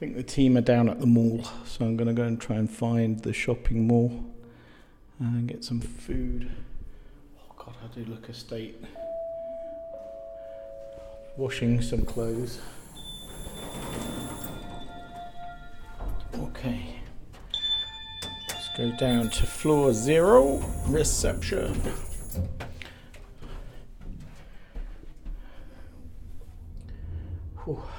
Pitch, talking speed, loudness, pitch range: 115 Hz, 90 wpm, -27 LUFS, 90-120 Hz